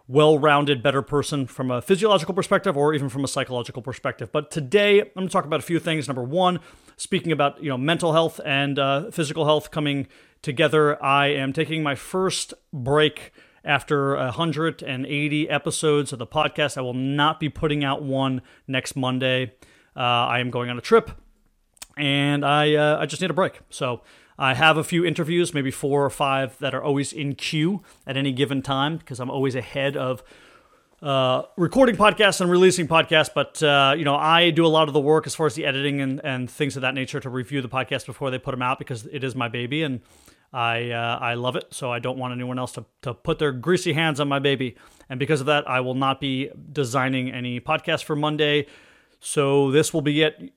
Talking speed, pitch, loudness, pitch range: 210 wpm, 145 Hz, -22 LUFS, 130-155 Hz